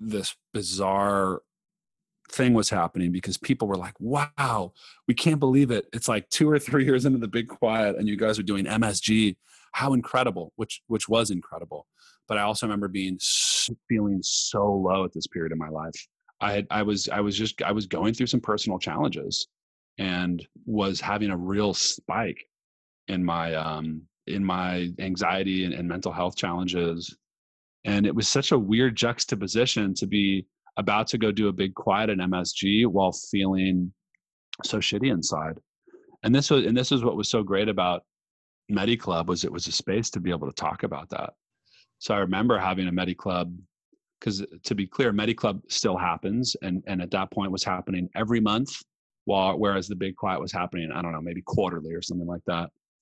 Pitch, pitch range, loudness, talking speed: 100 Hz, 90-110 Hz, -26 LUFS, 190 wpm